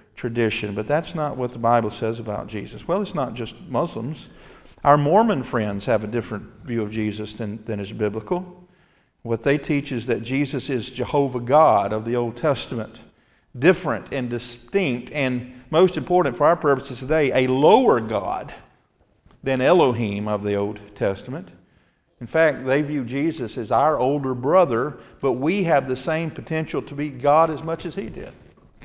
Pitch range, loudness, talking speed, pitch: 115-150 Hz, -22 LUFS, 175 wpm, 130 Hz